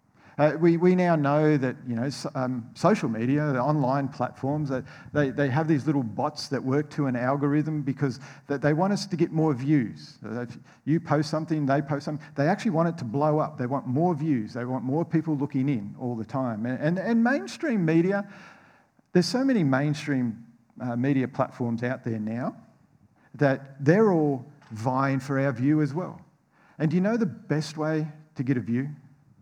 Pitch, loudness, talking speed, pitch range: 145 Hz, -26 LUFS, 200 wpm, 130-155 Hz